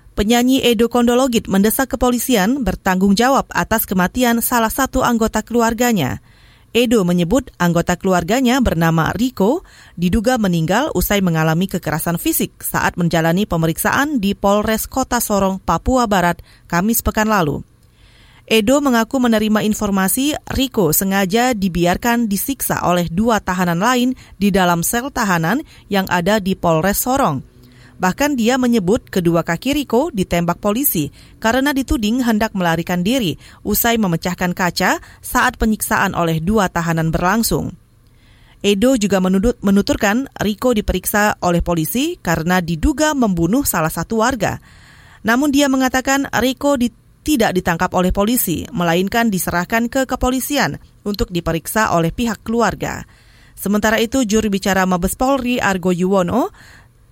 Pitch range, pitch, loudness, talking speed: 175-245 Hz, 205 Hz, -17 LUFS, 125 wpm